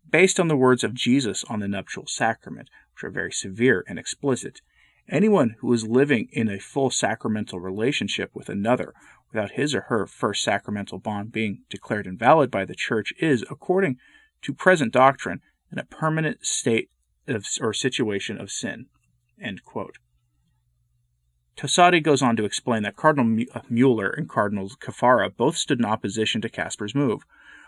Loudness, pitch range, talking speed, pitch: -23 LUFS, 95-140 Hz, 155 wpm, 110 Hz